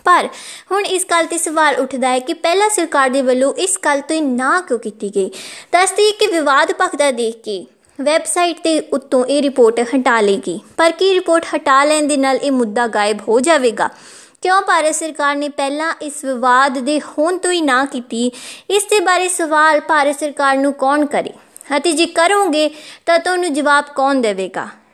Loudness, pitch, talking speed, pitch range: -15 LUFS, 295 Hz, 190 wpm, 265-335 Hz